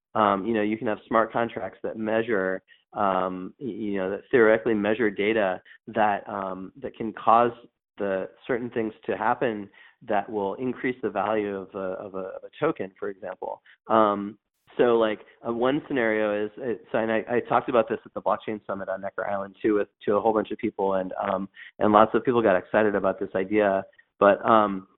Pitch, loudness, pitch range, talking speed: 105 Hz, -25 LUFS, 95-115 Hz, 195 wpm